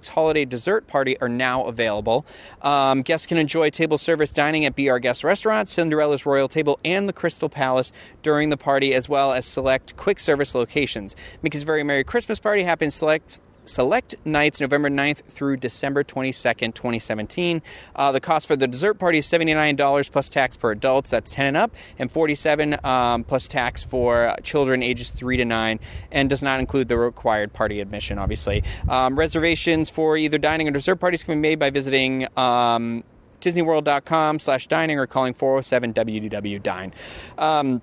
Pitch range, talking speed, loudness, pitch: 125-155 Hz, 175 wpm, -21 LUFS, 140 Hz